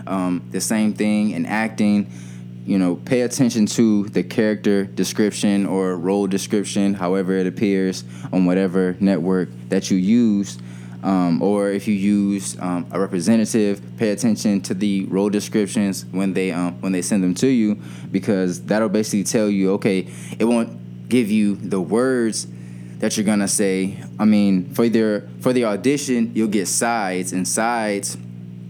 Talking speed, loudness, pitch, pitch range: 160 wpm, -20 LUFS, 100 Hz, 90-105 Hz